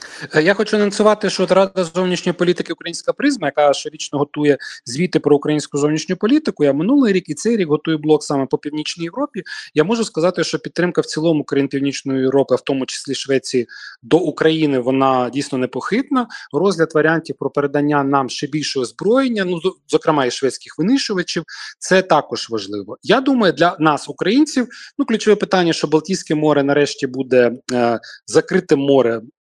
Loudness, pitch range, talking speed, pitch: -17 LUFS, 140-190 Hz, 165 wpm, 155 Hz